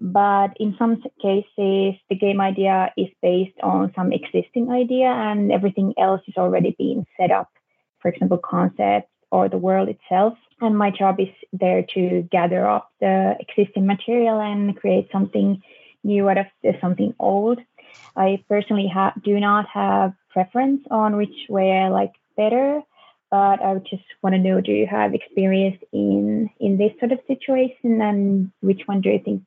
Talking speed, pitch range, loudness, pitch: 170 wpm, 190-215 Hz, -20 LUFS, 195 Hz